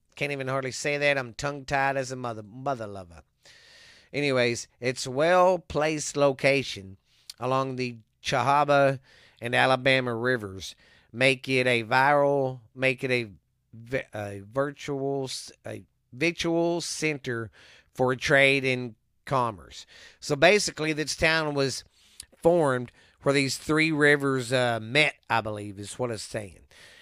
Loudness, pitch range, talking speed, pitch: -25 LUFS, 120-140 Hz, 125 wpm, 130 Hz